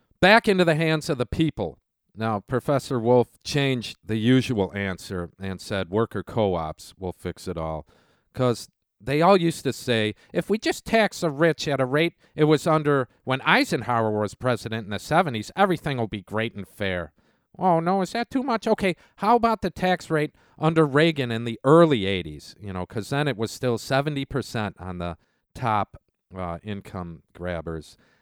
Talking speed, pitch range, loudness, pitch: 185 wpm, 100-160 Hz, -24 LUFS, 125 Hz